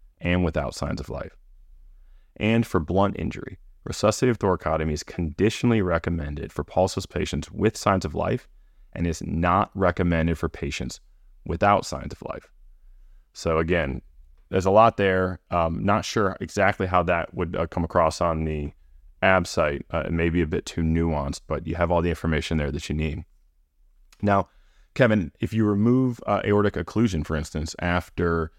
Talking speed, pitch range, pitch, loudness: 170 wpm, 75-95 Hz, 85 Hz, -24 LUFS